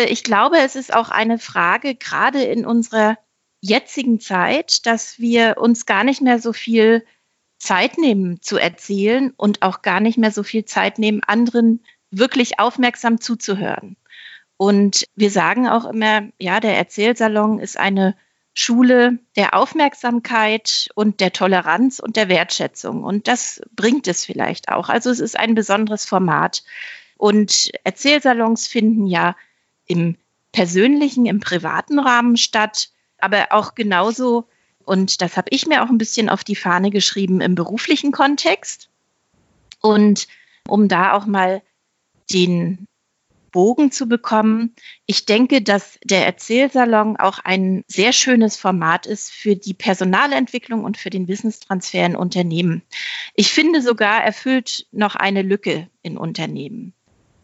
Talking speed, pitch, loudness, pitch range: 140 wpm, 215 Hz, -17 LUFS, 190-240 Hz